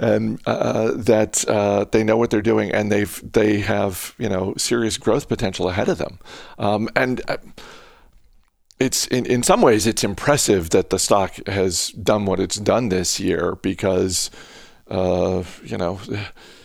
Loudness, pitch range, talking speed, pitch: -20 LUFS, 95-110 Hz, 160 wpm, 105 Hz